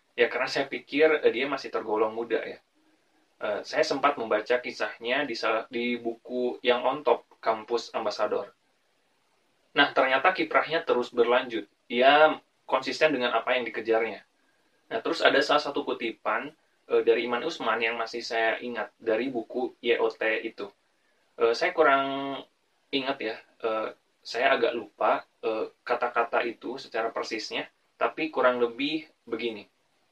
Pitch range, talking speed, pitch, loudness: 115-155 Hz, 140 wpm, 125 Hz, -27 LUFS